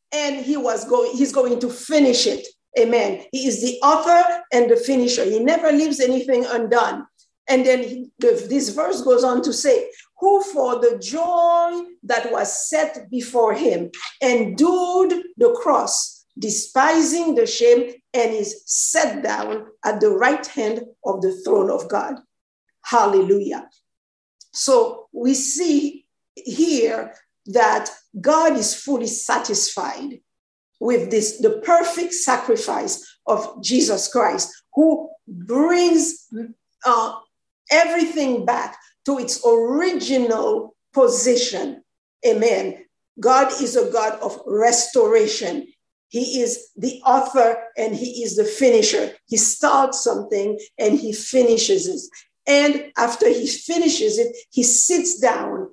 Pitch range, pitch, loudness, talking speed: 240-340 Hz, 265 Hz, -19 LUFS, 125 wpm